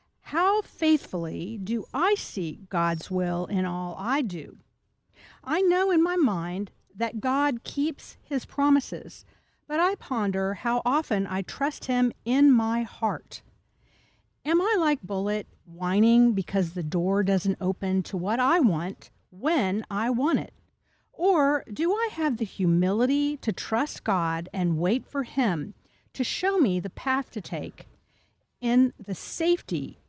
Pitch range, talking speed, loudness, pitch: 190-290 Hz, 145 wpm, -26 LUFS, 235 Hz